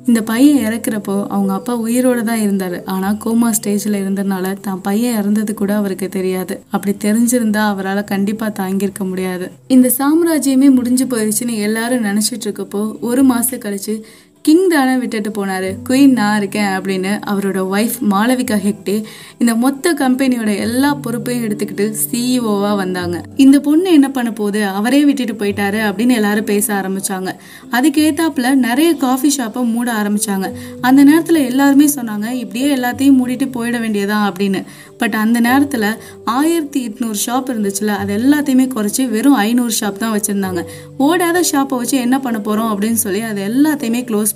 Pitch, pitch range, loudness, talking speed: 225 Hz, 205-255 Hz, -15 LUFS, 145 wpm